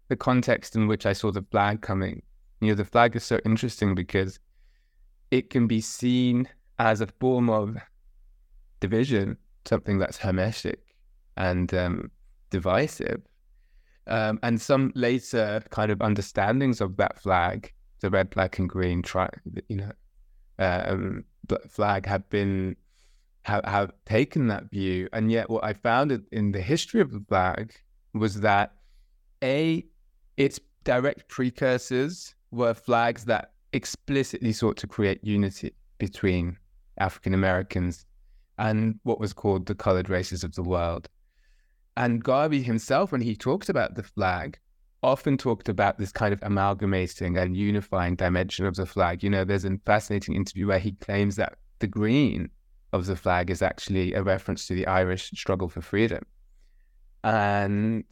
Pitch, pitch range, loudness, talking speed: 100 Hz, 95-115 Hz, -26 LUFS, 150 wpm